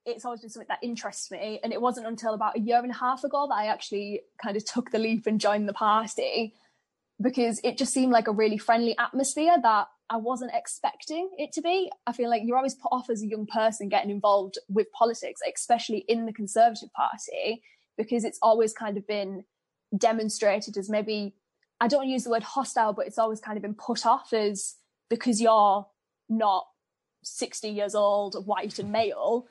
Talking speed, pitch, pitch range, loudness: 200 wpm, 225 Hz, 210-240 Hz, -27 LUFS